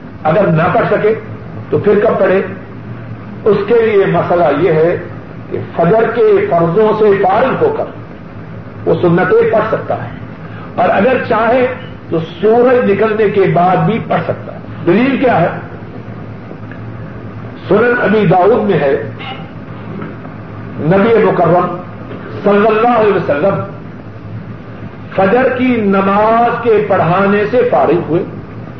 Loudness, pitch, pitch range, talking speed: -11 LUFS, 195 Hz, 160-220 Hz, 125 wpm